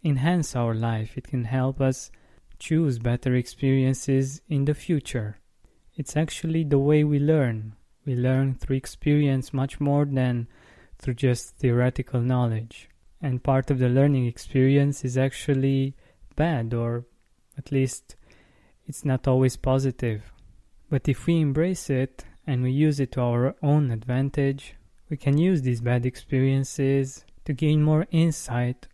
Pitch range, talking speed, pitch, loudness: 125-145 Hz, 145 wpm, 135 Hz, -25 LUFS